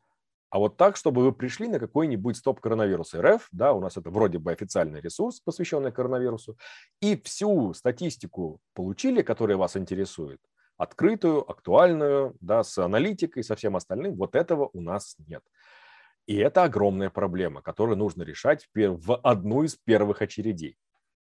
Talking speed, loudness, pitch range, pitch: 155 wpm, -26 LUFS, 100-140 Hz, 115 Hz